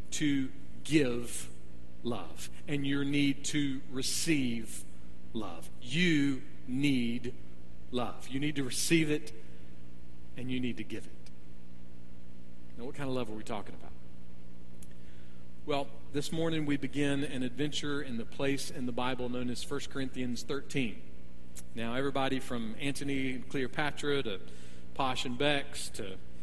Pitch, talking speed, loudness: 125 Hz, 140 wpm, -34 LUFS